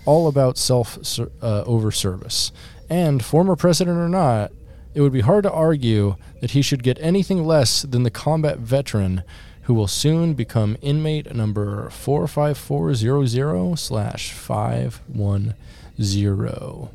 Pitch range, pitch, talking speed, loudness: 105-150 Hz, 130 Hz, 125 wpm, -20 LUFS